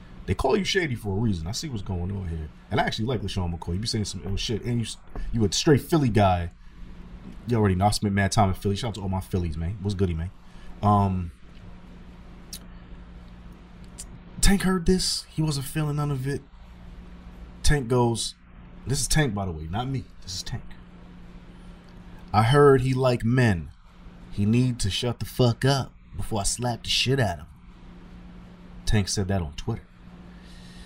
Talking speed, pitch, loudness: 195 wpm, 100 Hz, -25 LUFS